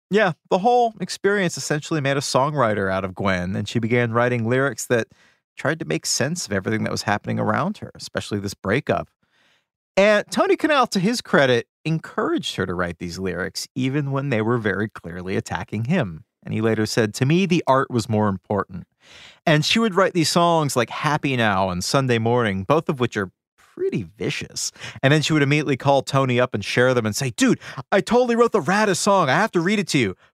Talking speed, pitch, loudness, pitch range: 210 wpm, 135 Hz, -21 LUFS, 110-175 Hz